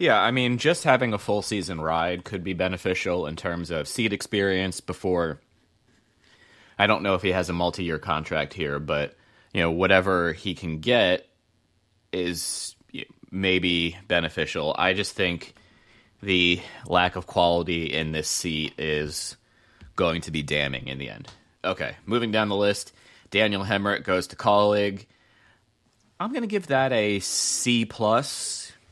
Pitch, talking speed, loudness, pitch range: 95 Hz, 155 wpm, -25 LUFS, 85-105 Hz